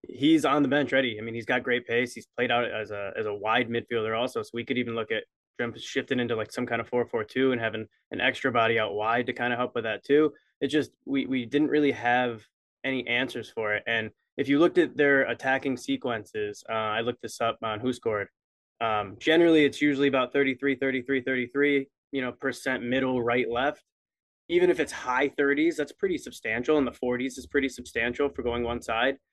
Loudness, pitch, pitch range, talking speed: -27 LUFS, 125 Hz, 120-140 Hz, 225 wpm